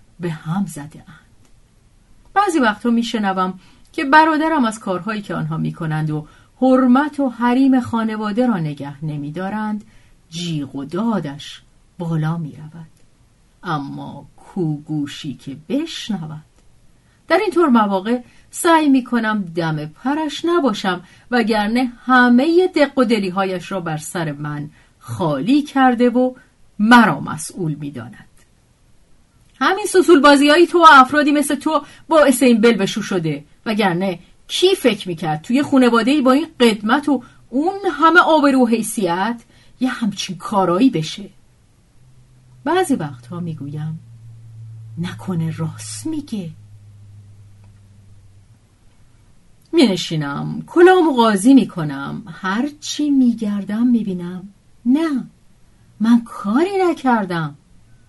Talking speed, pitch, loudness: 115 wpm, 210 Hz, -17 LUFS